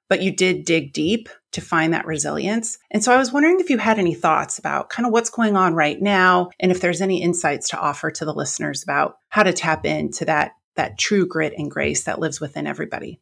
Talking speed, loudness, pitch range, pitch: 235 wpm, -20 LUFS, 165-220 Hz, 185 Hz